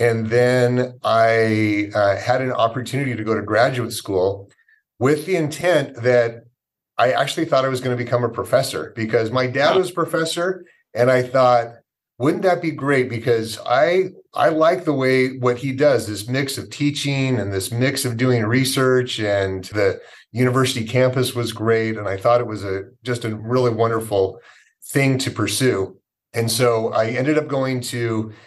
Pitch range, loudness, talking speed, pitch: 115-130 Hz, -19 LUFS, 175 wpm, 125 Hz